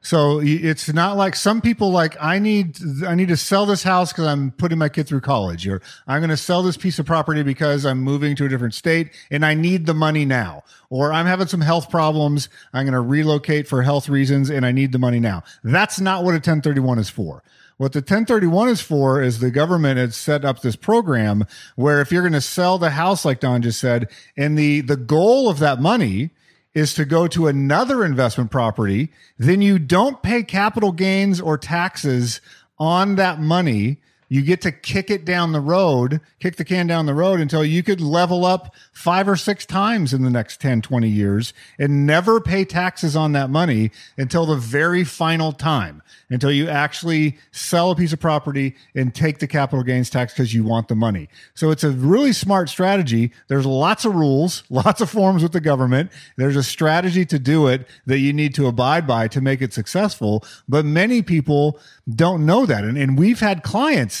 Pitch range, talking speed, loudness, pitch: 135-180 Hz, 210 wpm, -18 LUFS, 150 Hz